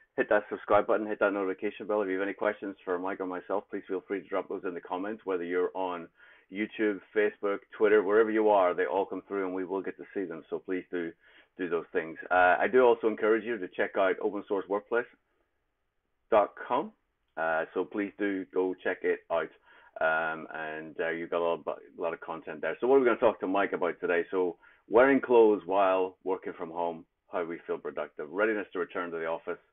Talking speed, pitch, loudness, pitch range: 225 wpm, 95 Hz, -30 LUFS, 90-105 Hz